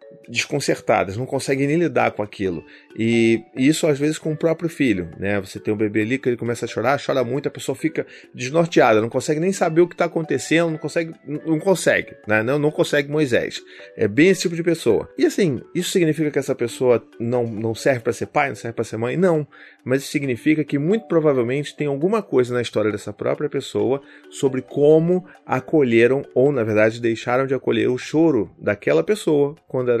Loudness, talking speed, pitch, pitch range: -20 LUFS, 210 wpm, 140 Hz, 120-160 Hz